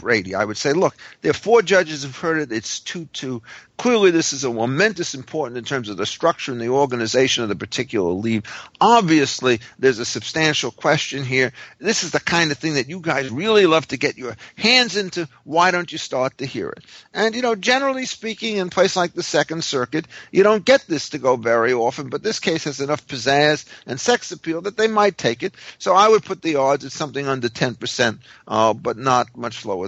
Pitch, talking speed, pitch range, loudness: 150 Hz, 220 wpm, 130-185 Hz, -19 LUFS